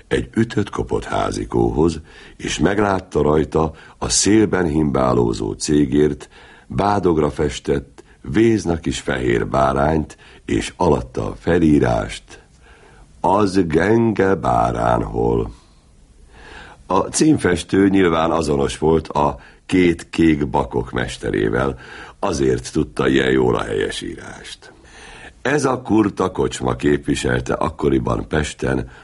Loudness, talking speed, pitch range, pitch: -18 LUFS, 100 wpm, 70-95 Hz, 80 Hz